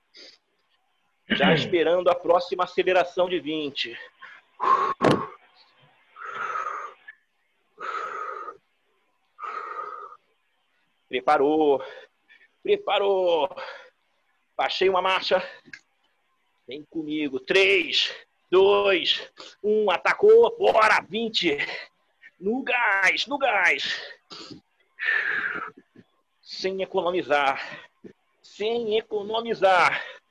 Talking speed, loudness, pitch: 55 wpm, -23 LUFS, 230 Hz